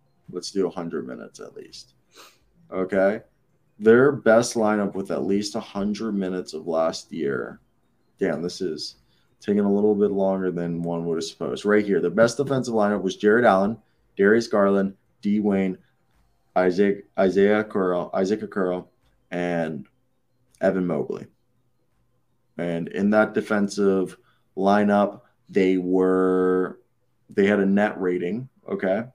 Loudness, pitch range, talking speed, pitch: -23 LUFS, 90-105 Hz, 135 wpm, 100 Hz